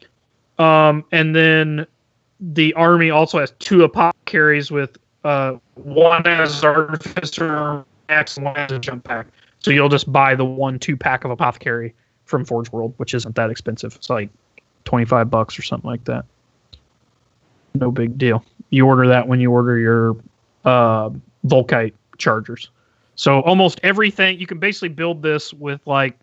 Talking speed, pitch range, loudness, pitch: 155 wpm, 120-155 Hz, -17 LUFS, 135 Hz